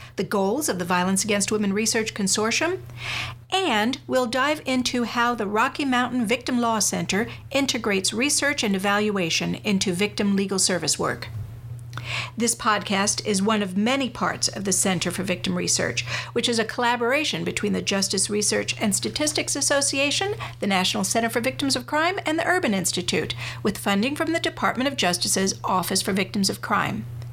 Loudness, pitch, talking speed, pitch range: -23 LUFS, 210 Hz, 165 wpm, 190-255 Hz